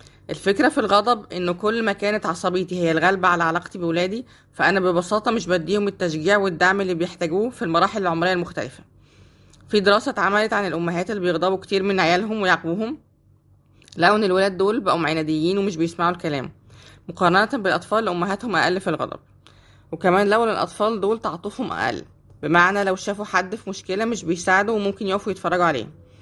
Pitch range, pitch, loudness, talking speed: 175-205 Hz, 185 Hz, -21 LUFS, 160 wpm